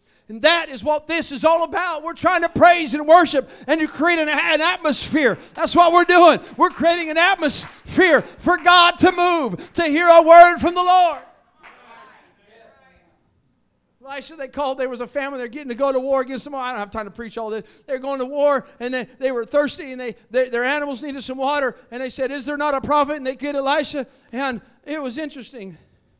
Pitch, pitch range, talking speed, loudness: 285 Hz, 260-330 Hz, 220 wpm, -17 LUFS